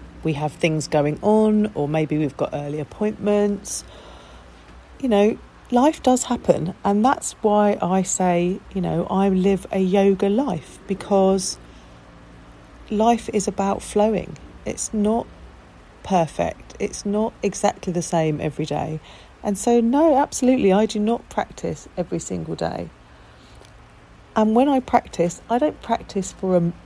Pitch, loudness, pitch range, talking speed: 195 Hz, -21 LUFS, 165-215 Hz, 140 wpm